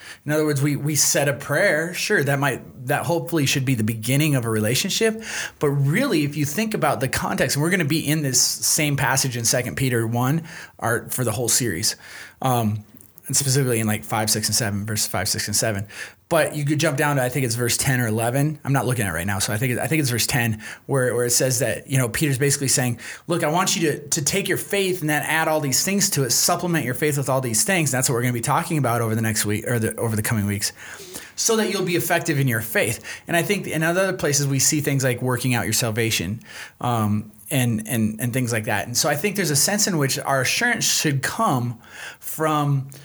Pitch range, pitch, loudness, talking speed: 120-155 Hz, 135 Hz, -21 LUFS, 255 wpm